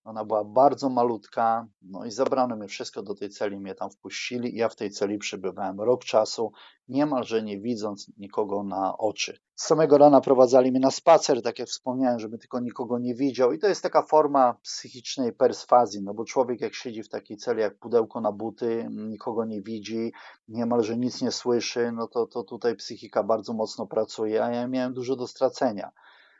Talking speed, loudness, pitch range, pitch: 190 wpm, -25 LUFS, 110-125 Hz, 120 Hz